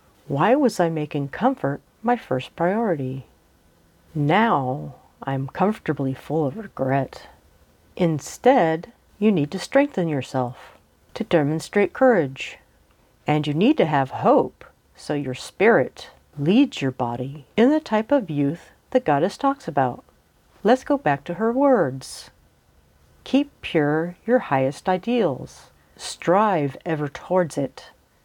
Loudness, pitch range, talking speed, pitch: -22 LUFS, 135-220 Hz, 125 wpm, 155 Hz